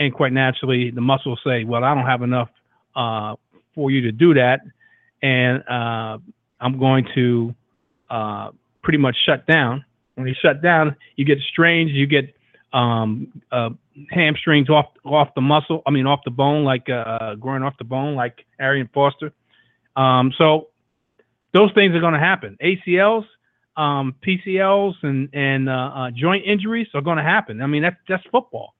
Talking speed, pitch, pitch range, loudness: 175 wpm, 140 Hz, 125-160 Hz, -19 LUFS